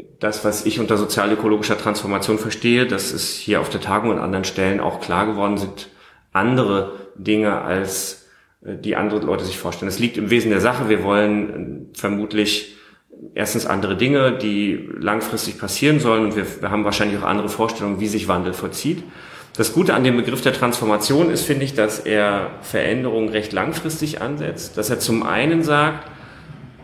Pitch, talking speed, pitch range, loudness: 105 Hz, 170 wpm, 100-120 Hz, -20 LUFS